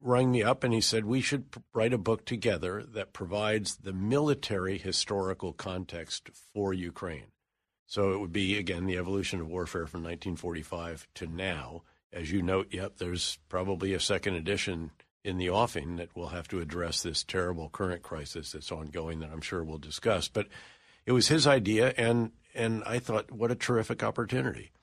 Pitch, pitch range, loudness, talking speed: 95 Hz, 85-110 Hz, -31 LUFS, 180 wpm